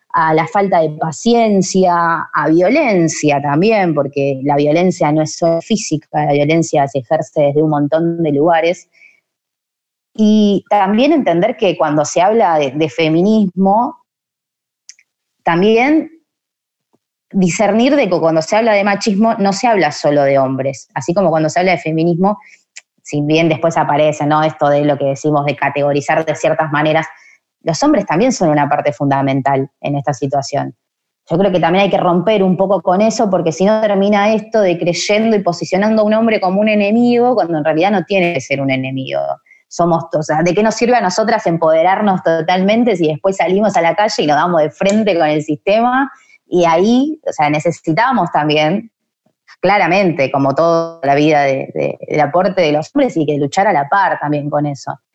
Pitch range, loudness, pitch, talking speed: 150-200 Hz, -14 LUFS, 170 Hz, 185 wpm